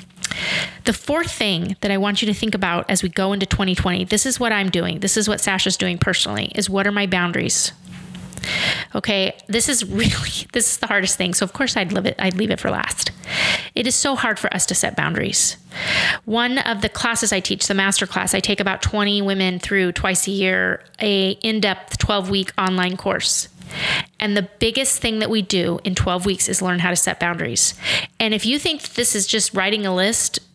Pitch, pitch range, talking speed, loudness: 200 Hz, 185-220 Hz, 215 wpm, -19 LUFS